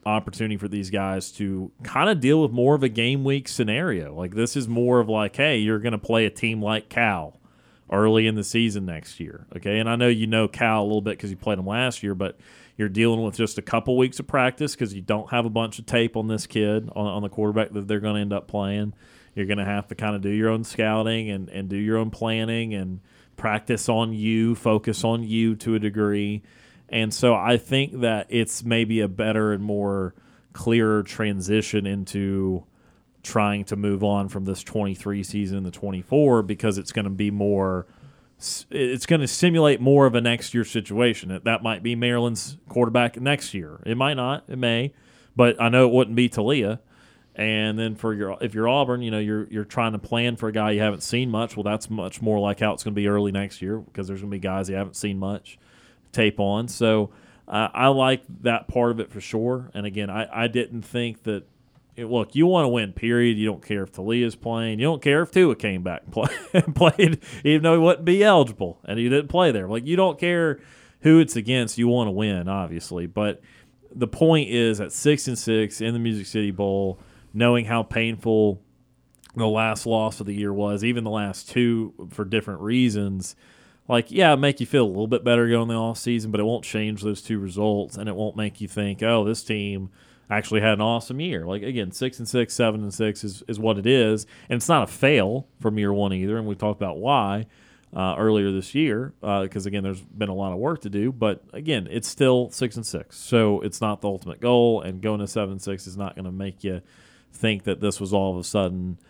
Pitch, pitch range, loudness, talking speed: 110 Hz, 100-120 Hz, -23 LUFS, 230 wpm